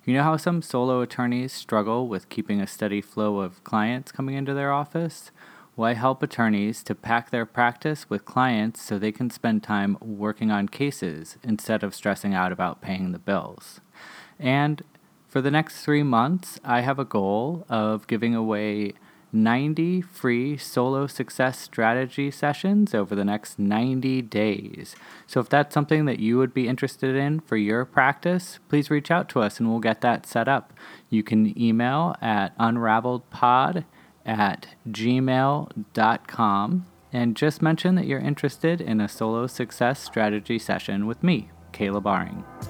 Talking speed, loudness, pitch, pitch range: 160 wpm, -24 LUFS, 120 Hz, 110-145 Hz